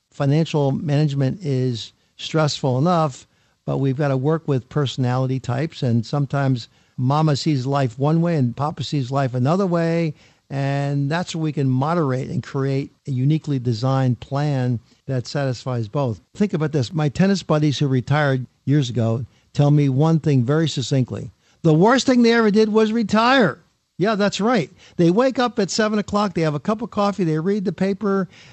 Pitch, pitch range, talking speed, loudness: 145 Hz, 130-170 Hz, 175 wpm, -20 LUFS